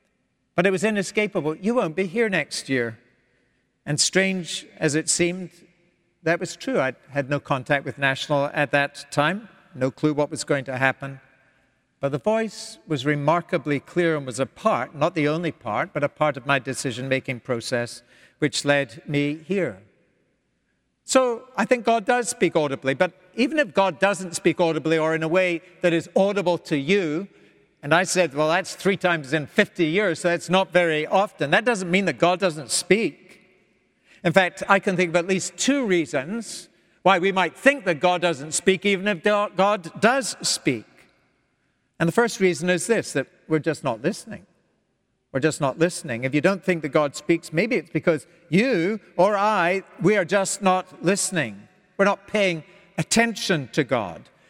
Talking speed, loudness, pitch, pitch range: 185 wpm, -23 LUFS, 175 Hz, 150-195 Hz